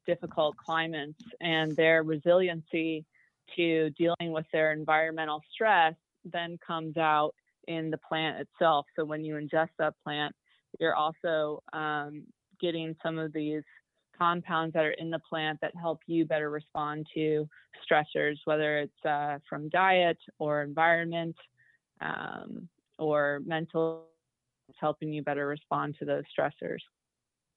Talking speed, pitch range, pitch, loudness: 135 wpm, 150-165 Hz, 160 Hz, -30 LUFS